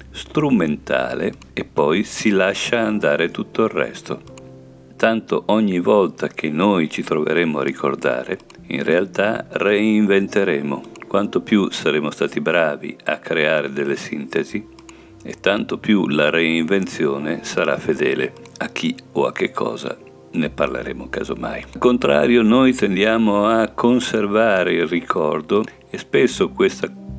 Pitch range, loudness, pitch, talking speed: 80-115 Hz, -19 LUFS, 105 Hz, 125 wpm